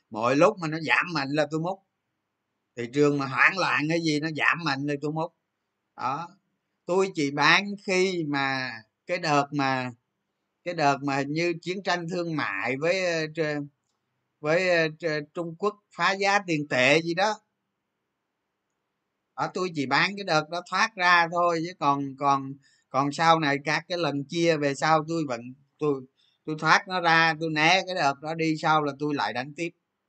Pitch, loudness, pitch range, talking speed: 160 Hz, -25 LUFS, 140-175 Hz, 180 wpm